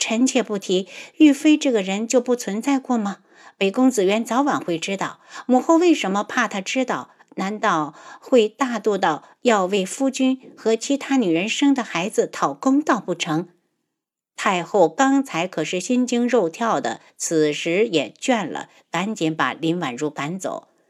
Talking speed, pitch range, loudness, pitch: 235 characters per minute, 185-265 Hz, -21 LUFS, 225 Hz